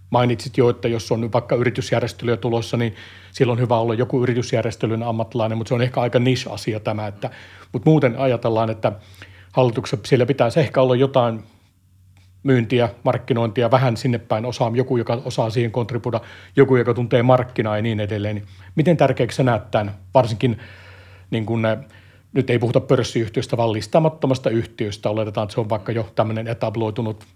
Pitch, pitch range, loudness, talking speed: 120 Hz, 110-125 Hz, -20 LUFS, 165 wpm